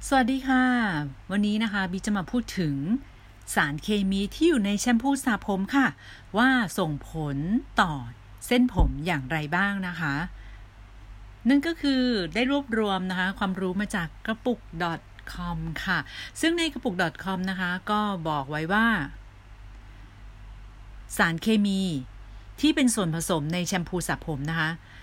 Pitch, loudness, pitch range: 185 Hz, -26 LUFS, 145-220 Hz